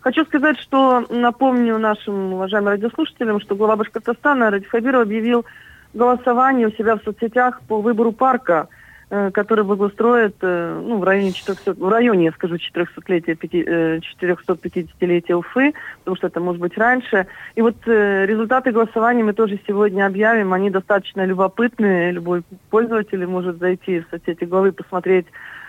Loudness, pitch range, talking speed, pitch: -18 LUFS, 185-235 Hz, 130 wpm, 205 Hz